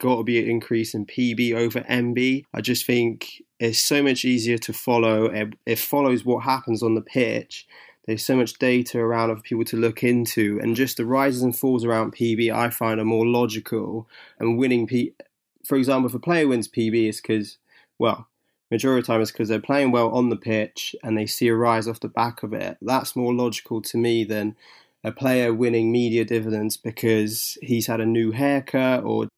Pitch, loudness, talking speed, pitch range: 115 Hz, -22 LUFS, 210 wpm, 115-125 Hz